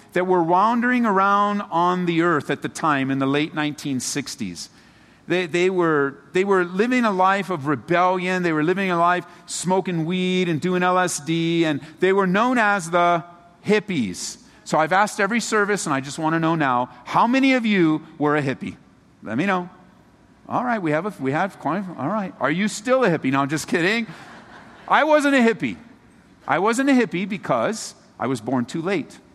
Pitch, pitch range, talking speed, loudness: 180 Hz, 155-205 Hz, 200 wpm, -21 LUFS